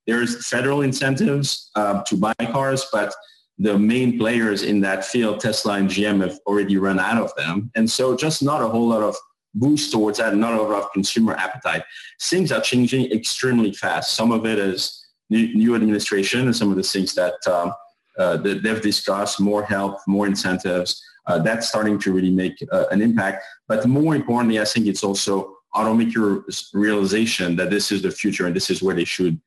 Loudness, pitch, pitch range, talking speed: -20 LUFS, 105 Hz, 100-115 Hz, 190 wpm